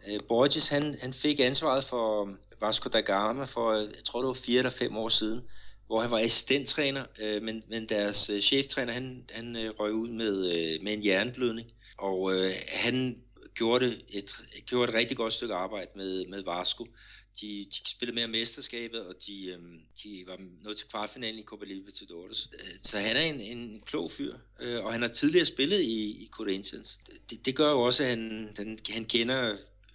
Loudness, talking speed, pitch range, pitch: -29 LUFS, 175 wpm, 105-125 Hz, 115 Hz